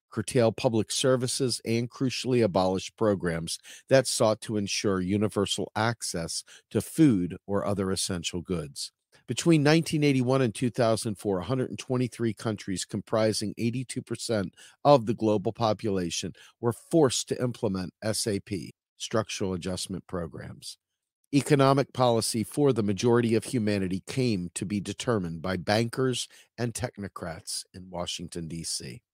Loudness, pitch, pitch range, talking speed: -28 LUFS, 110 Hz, 95-125 Hz, 115 wpm